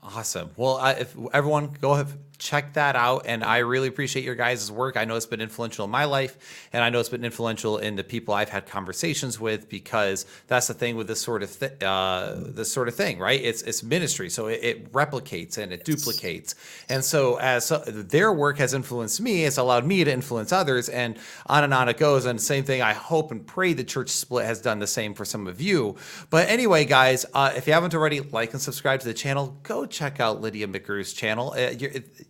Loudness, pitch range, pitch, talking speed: -24 LUFS, 115-140 Hz, 125 Hz, 230 wpm